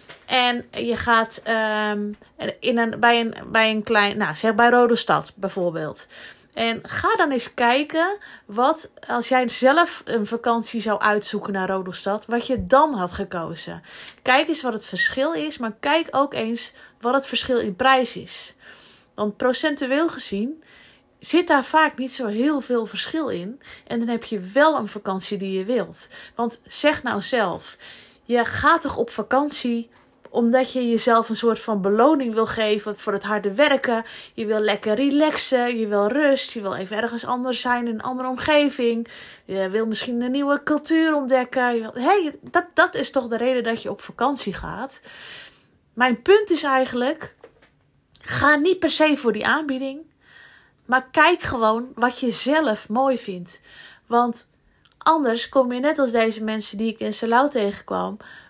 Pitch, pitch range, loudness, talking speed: 240 Hz, 220-270 Hz, -21 LUFS, 170 wpm